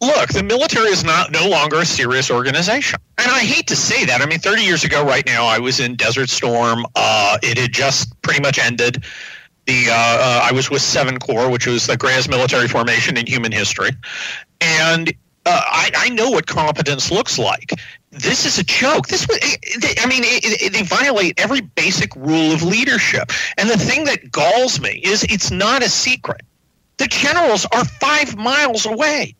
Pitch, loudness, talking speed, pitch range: 135 Hz, -15 LUFS, 195 wpm, 125-170 Hz